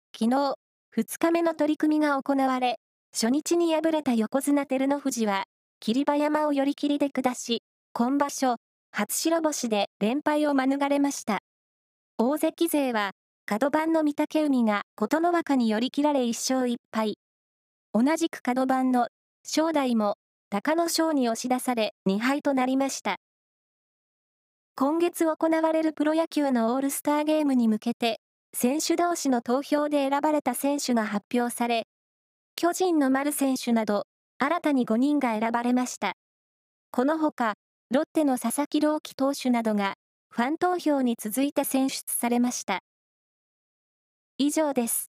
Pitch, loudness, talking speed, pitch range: 275 Hz, -26 LUFS, 265 characters per minute, 240-300 Hz